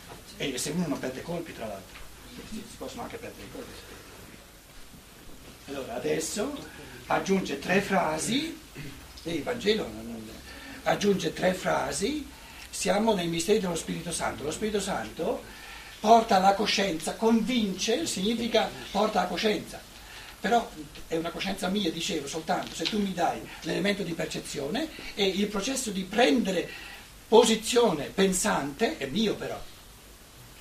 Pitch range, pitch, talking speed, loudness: 170-225 Hz, 195 Hz, 140 wpm, -28 LUFS